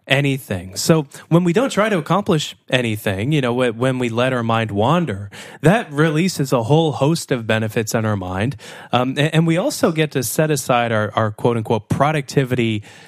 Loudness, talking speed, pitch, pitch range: -18 LUFS, 185 wpm, 135 Hz, 115-155 Hz